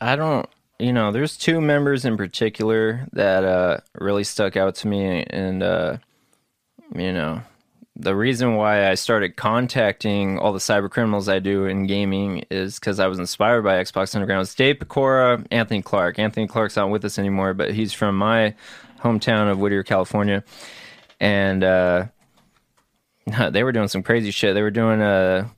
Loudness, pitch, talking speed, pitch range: -21 LUFS, 100 Hz, 175 wpm, 95-115 Hz